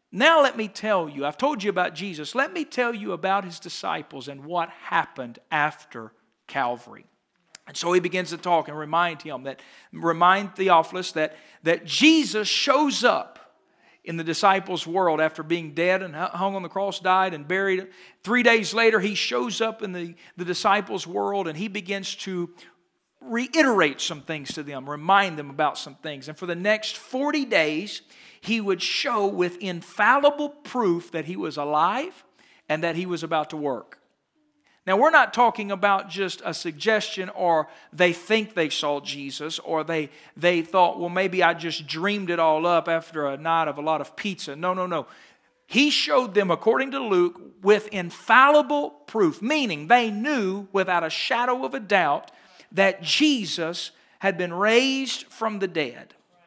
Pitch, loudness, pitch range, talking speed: 185 Hz, -23 LUFS, 165-215 Hz, 175 wpm